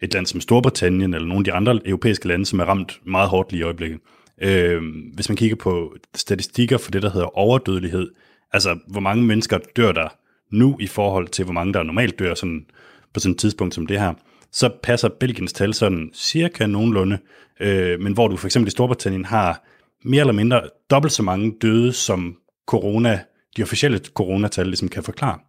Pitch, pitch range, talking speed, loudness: 100 Hz, 90-115 Hz, 200 wpm, -20 LUFS